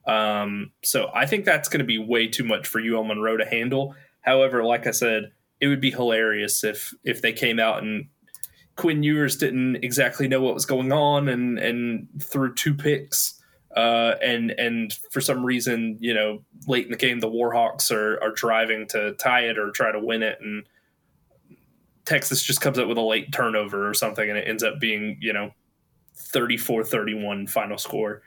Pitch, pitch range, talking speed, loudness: 115 Hz, 110-130 Hz, 195 wpm, -23 LUFS